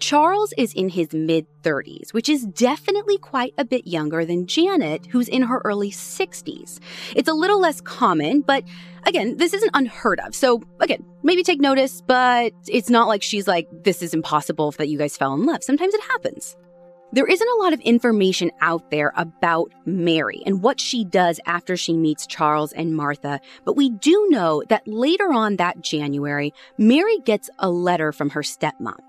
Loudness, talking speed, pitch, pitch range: -20 LUFS, 185 wpm, 200 Hz, 165-275 Hz